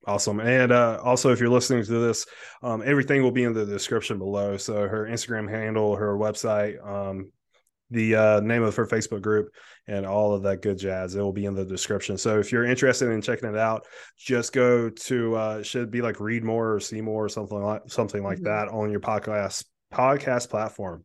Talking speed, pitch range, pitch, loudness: 215 wpm, 105-120 Hz, 110 Hz, -25 LUFS